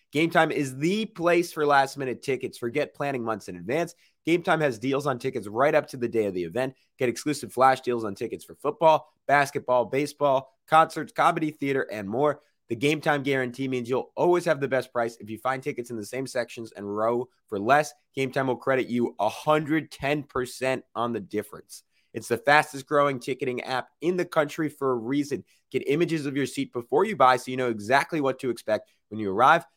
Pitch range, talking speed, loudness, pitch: 120-150 Hz, 205 wpm, -26 LUFS, 135 Hz